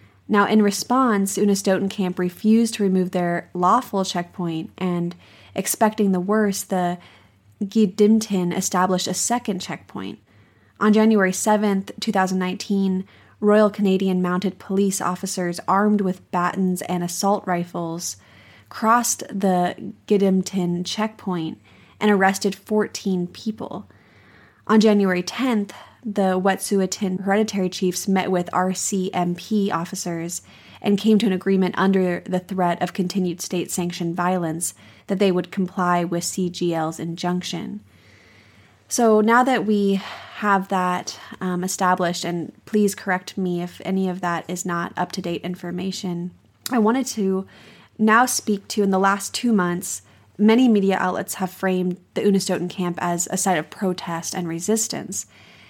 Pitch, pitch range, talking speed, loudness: 185 Hz, 175-205 Hz, 130 wpm, -21 LUFS